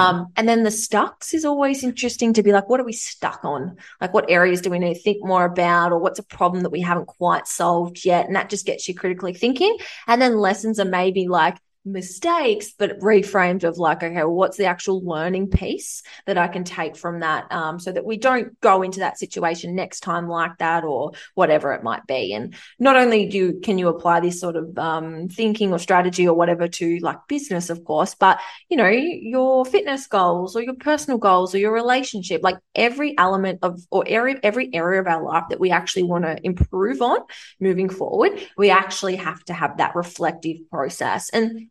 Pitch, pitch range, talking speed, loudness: 185 Hz, 175-225 Hz, 215 wpm, -20 LUFS